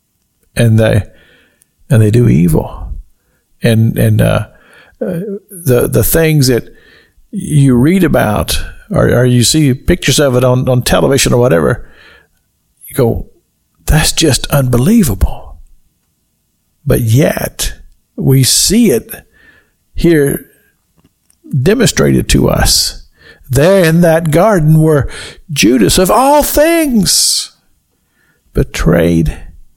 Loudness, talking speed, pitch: -10 LUFS, 105 wpm, 125 Hz